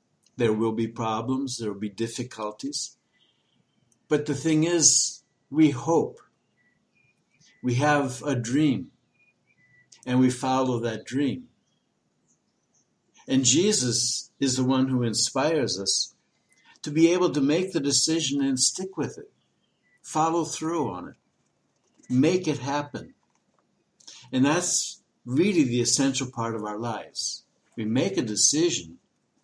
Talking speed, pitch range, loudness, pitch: 125 wpm, 120-150 Hz, -25 LUFS, 135 Hz